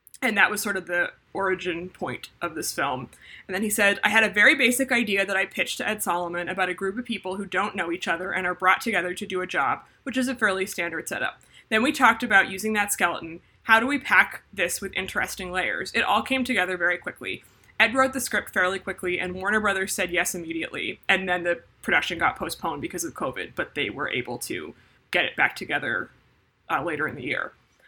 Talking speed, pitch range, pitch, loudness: 230 wpm, 180-215 Hz, 190 Hz, -24 LUFS